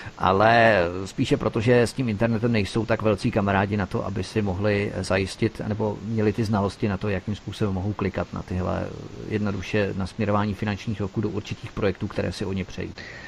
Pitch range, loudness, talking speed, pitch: 95-110 Hz, -25 LUFS, 185 wpm, 105 Hz